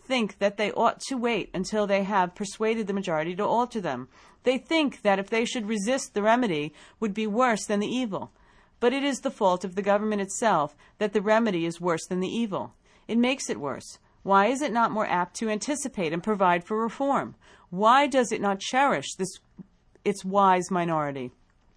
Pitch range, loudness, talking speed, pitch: 190-235 Hz, -26 LUFS, 200 wpm, 210 Hz